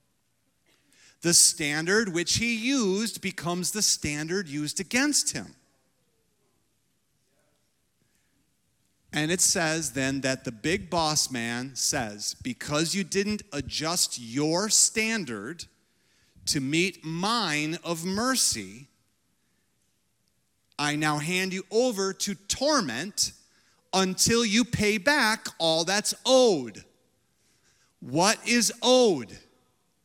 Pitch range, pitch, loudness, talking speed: 150-215 Hz, 180 Hz, -25 LUFS, 100 wpm